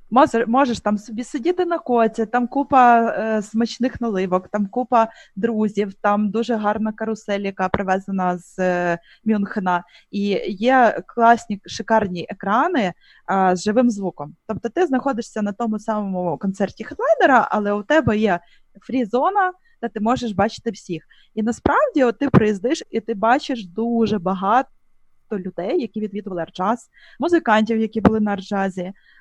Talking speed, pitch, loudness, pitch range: 145 wpm, 220 Hz, -20 LUFS, 200-240 Hz